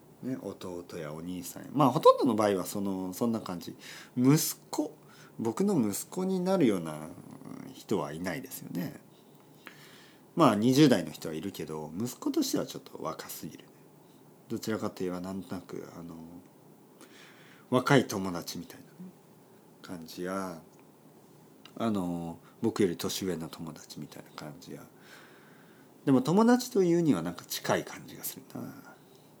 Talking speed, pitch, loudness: 270 characters per minute, 105 Hz, -30 LUFS